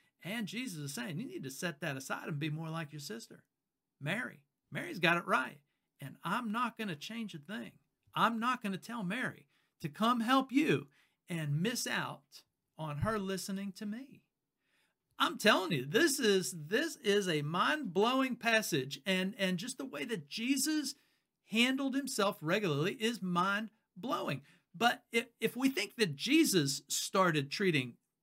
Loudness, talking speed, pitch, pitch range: -34 LUFS, 165 wpm, 200 Hz, 165-235 Hz